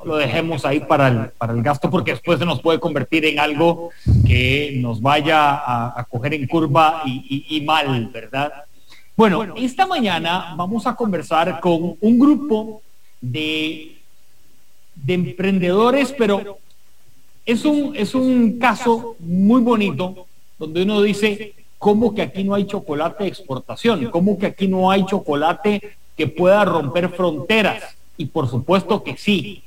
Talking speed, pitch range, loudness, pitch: 150 wpm, 150-205 Hz, -18 LUFS, 175 Hz